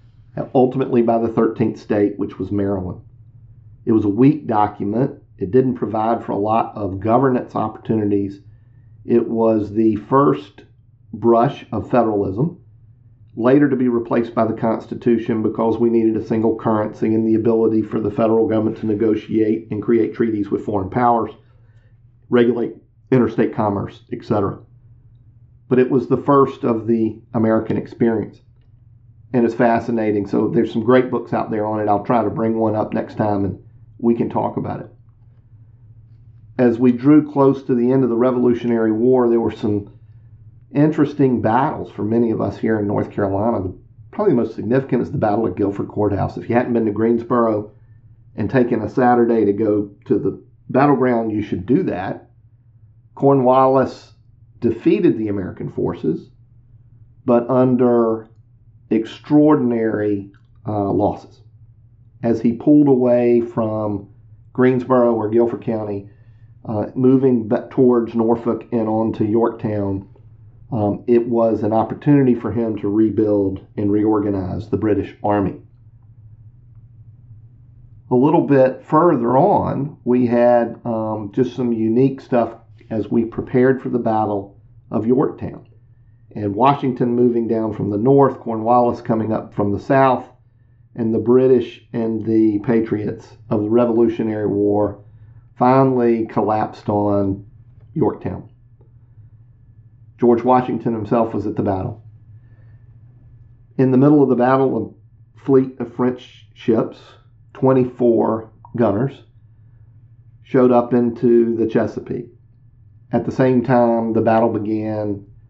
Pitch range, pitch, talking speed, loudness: 110-120 Hz, 115 Hz, 140 wpm, -18 LUFS